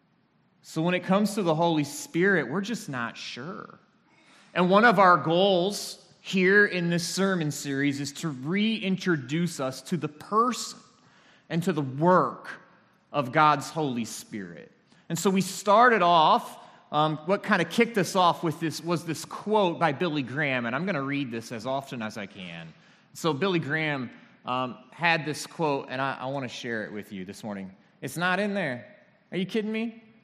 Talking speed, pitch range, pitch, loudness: 185 wpm, 140-190 Hz, 165 Hz, -26 LUFS